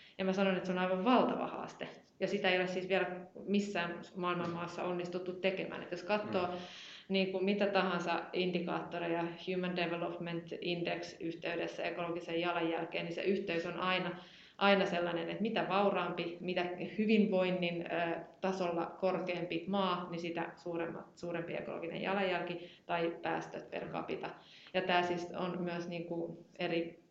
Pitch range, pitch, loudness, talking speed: 170-185 Hz, 175 Hz, -36 LUFS, 145 wpm